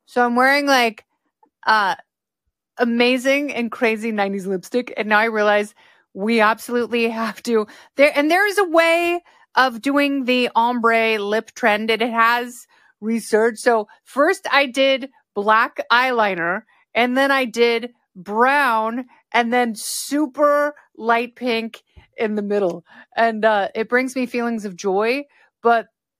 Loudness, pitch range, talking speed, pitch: -19 LUFS, 220-270 Hz, 140 wpm, 235 Hz